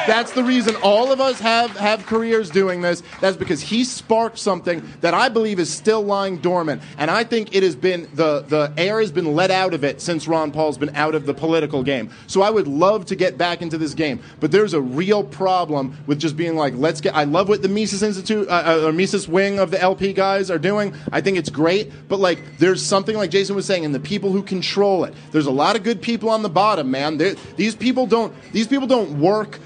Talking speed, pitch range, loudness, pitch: 245 wpm, 165-215 Hz, -19 LUFS, 190 Hz